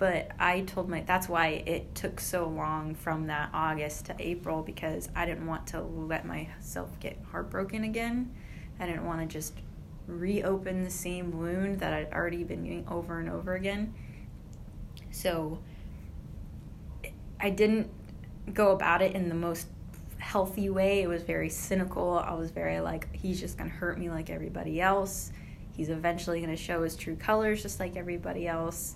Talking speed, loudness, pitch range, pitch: 170 wpm, -32 LUFS, 155-185 Hz, 170 Hz